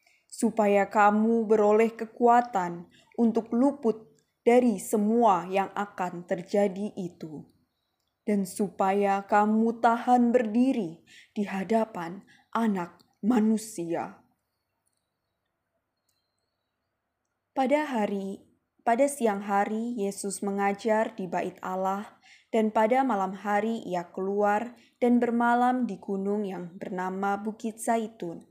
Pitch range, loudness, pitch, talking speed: 185-230 Hz, -27 LUFS, 205 Hz, 95 wpm